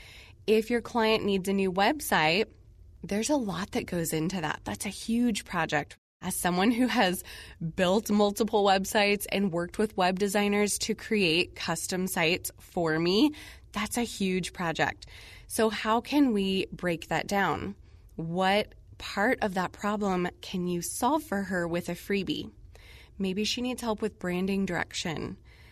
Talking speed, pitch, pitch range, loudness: 155 wpm, 195 Hz, 175-215 Hz, -28 LUFS